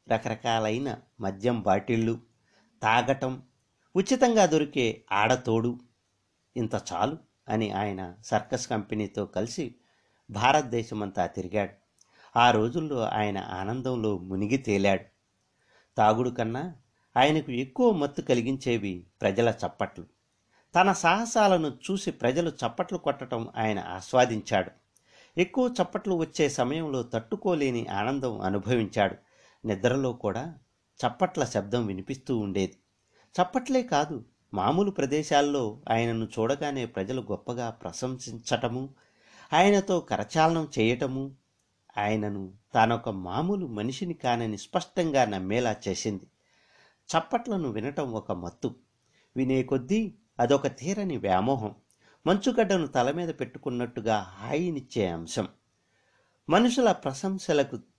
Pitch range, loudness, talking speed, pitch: 105-150 Hz, -28 LUFS, 90 wpm, 120 Hz